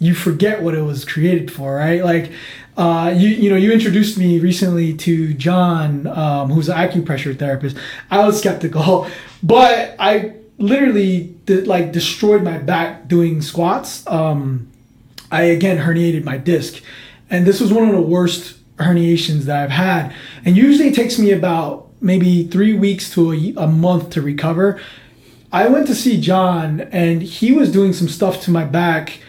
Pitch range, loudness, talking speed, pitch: 160-195 Hz, -15 LUFS, 170 wpm, 175 Hz